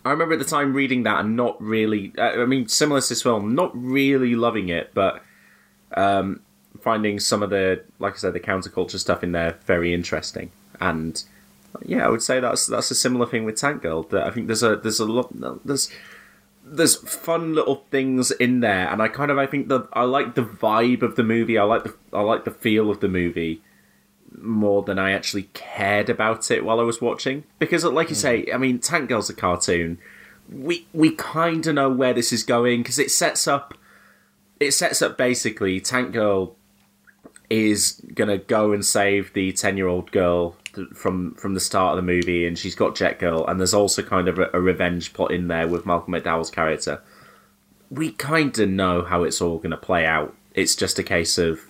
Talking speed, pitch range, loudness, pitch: 210 wpm, 90-125 Hz, -21 LUFS, 105 Hz